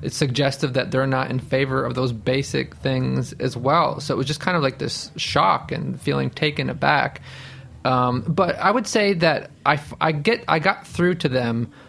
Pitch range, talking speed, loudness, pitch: 125-160 Hz, 200 wpm, -21 LUFS, 135 Hz